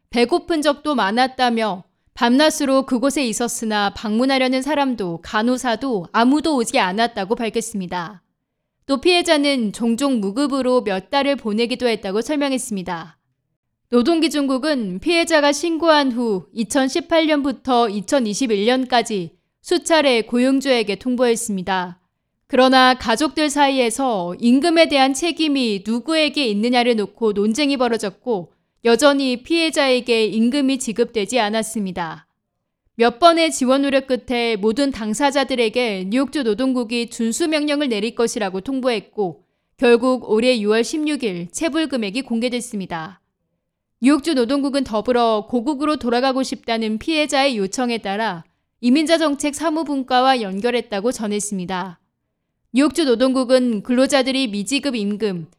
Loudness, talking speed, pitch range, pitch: -19 LUFS, 310 characters per minute, 220-280 Hz, 245 Hz